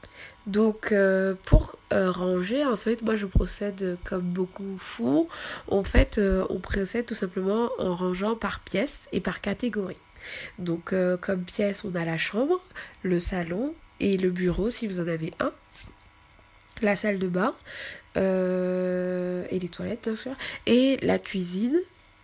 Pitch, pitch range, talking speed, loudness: 195 Hz, 185-220 Hz, 160 wpm, -26 LUFS